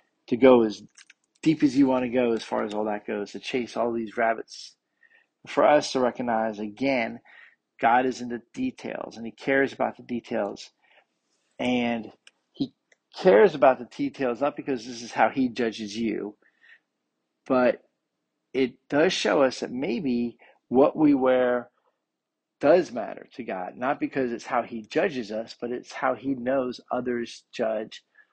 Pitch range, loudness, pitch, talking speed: 115-135 Hz, -25 LUFS, 125 Hz, 165 wpm